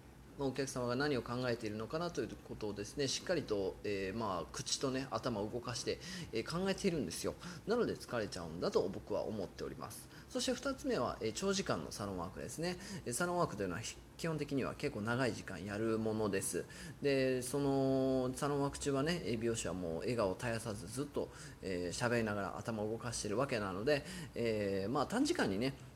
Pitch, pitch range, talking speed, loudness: 125 Hz, 110-145 Hz, 415 characters per minute, -38 LUFS